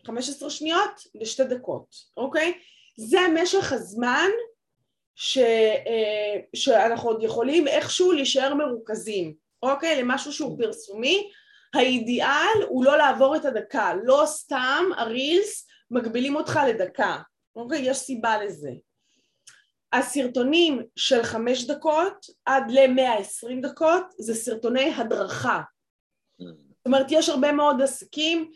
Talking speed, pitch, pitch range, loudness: 105 wpm, 270 Hz, 240-320 Hz, -23 LUFS